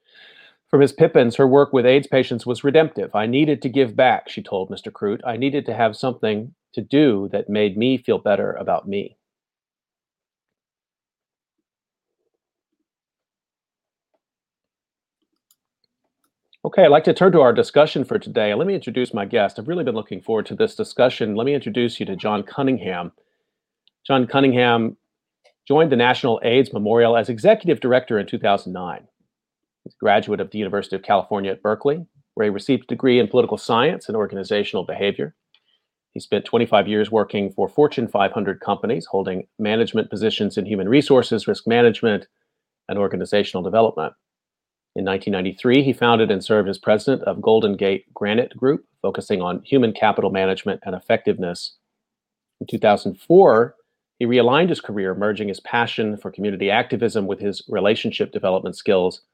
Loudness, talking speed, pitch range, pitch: -19 LUFS, 155 wpm, 105-145 Hz, 125 Hz